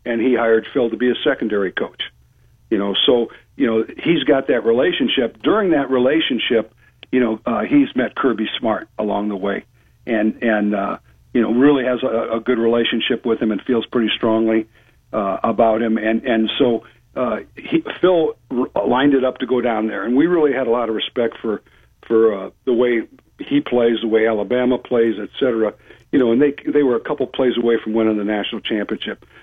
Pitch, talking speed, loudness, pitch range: 115 Hz, 205 wpm, -18 LUFS, 110-125 Hz